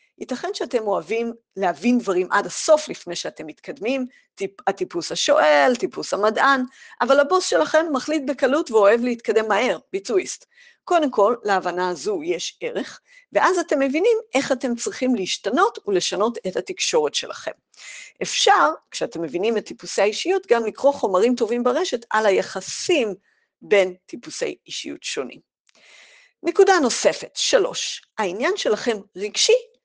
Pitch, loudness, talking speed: 265 Hz, -21 LUFS, 130 wpm